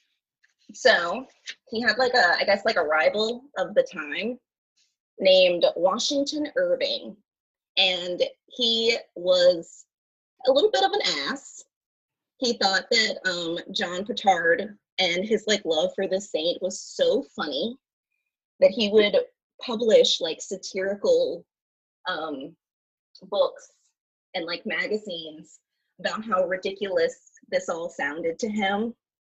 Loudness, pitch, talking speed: -24 LUFS, 225 Hz, 125 wpm